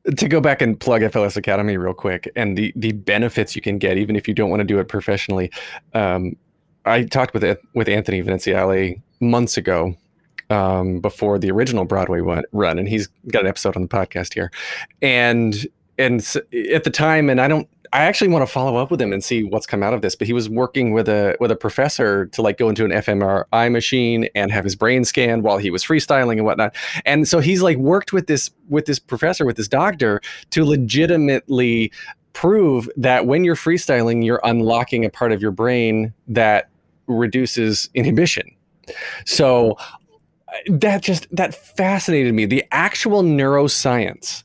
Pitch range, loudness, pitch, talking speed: 105-135 Hz, -18 LUFS, 115 Hz, 190 wpm